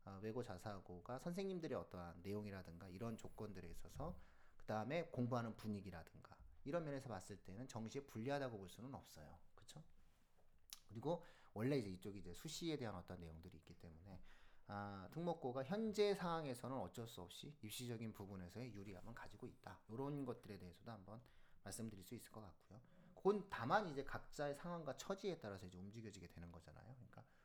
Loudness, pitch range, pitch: -49 LUFS, 95-135 Hz, 110 Hz